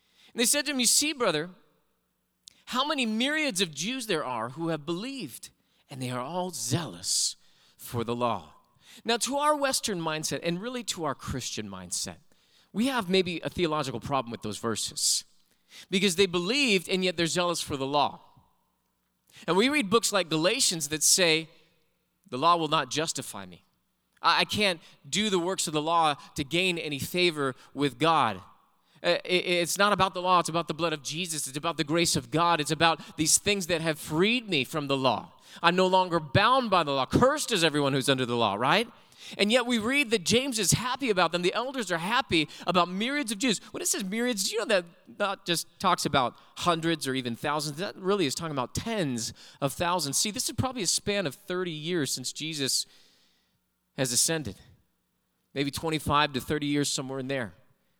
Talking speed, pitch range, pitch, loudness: 195 wpm, 145-200 Hz, 170 Hz, -27 LUFS